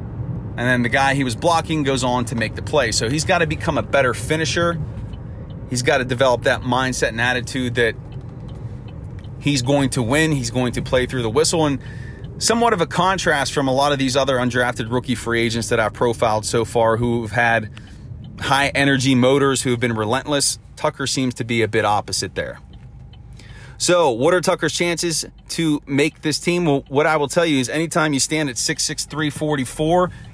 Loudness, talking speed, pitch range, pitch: -19 LUFS, 190 wpm, 120-150 Hz, 130 Hz